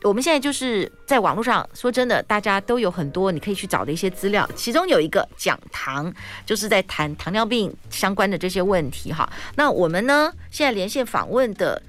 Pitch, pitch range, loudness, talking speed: 200 Hz, 185-245 Hz, -21 LUFS, 315 characters per minute